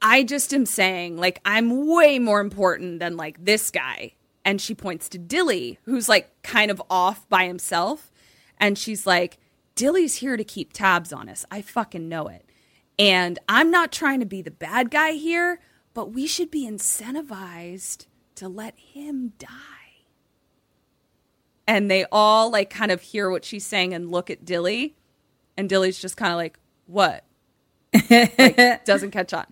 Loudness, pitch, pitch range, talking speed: -21 LUFS, 205 Hz, 185-250 Hz, 170 wpm